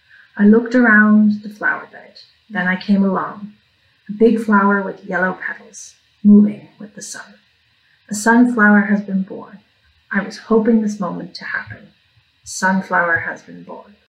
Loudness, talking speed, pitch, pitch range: -16 LUFS, 160 wpm, 205 Hz, 185-215 Hz